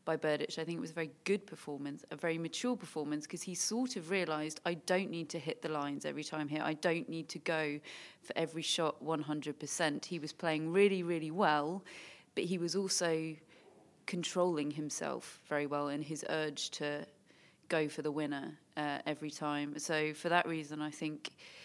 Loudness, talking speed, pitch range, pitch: -37 LUFS, 190 wpm, 150-175 Hz, 160 Hz